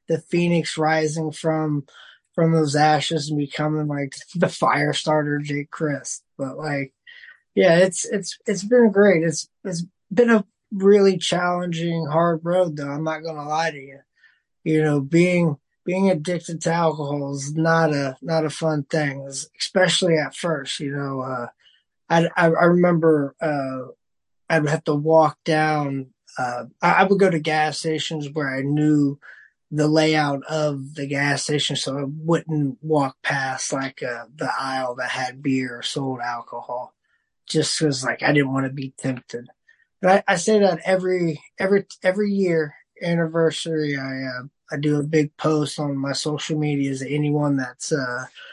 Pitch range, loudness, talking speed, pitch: 140-170 Hz, -21 LUFS, 165 wpm, 155 Hz